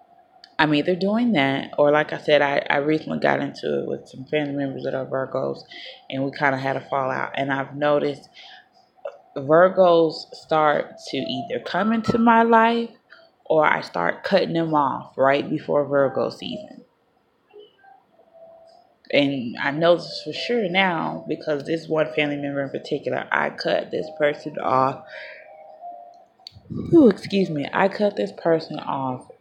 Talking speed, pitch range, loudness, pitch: 155 wpm, 140-225 Hz, -22 LUFS, 155 Hz